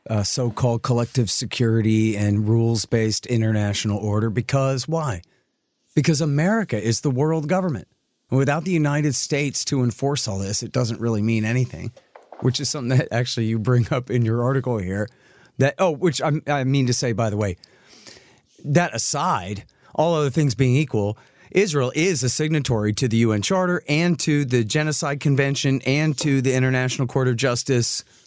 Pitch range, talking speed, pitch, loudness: 115-145 Hz, 170 wpm, 130 Hz, -21 LUFS